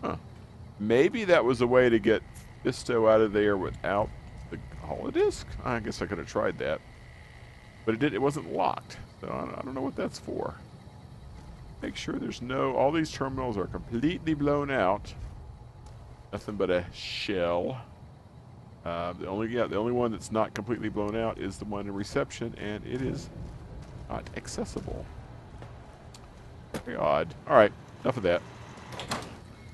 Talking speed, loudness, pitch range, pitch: 155 wpm, -29 LUFS, 105-125 Hz, 110 Hz